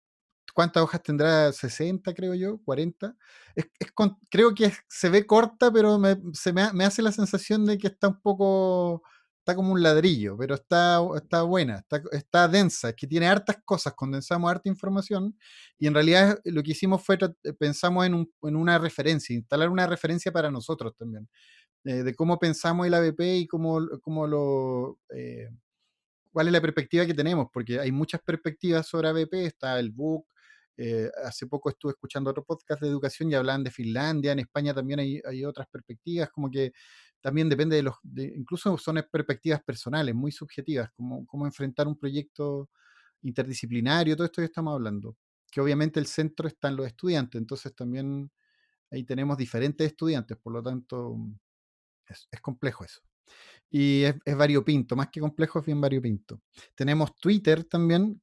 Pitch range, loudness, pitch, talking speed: 135-175 Hz, -26 LUFS, 155 Hz, 175 wpm